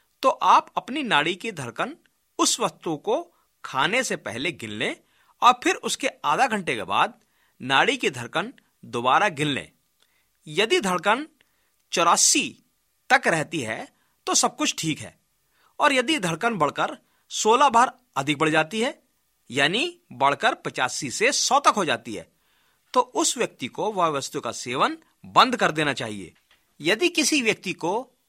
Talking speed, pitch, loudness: 155 wpm, 245 Hz, -23 LUFS